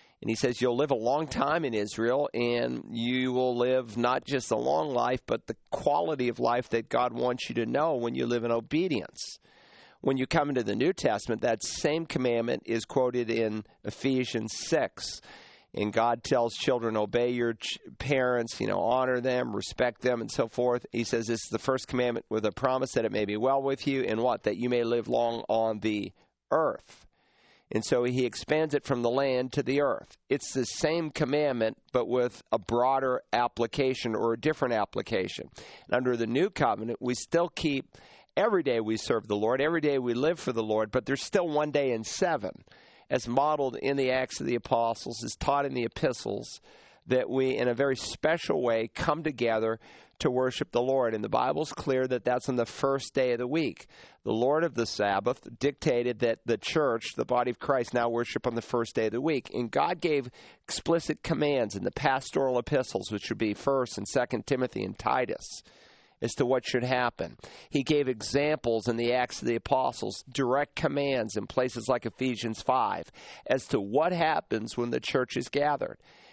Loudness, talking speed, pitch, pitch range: -29 LUFS, 200 wpm, 125 Hz, 115-135 Hz